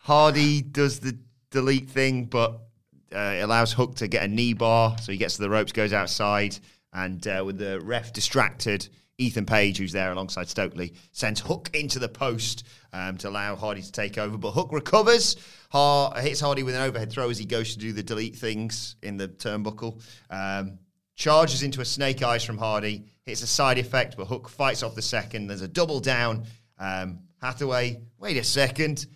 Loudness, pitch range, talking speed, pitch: -25 LUFS, 105-130 Hz, 195 wpm, 115 Hz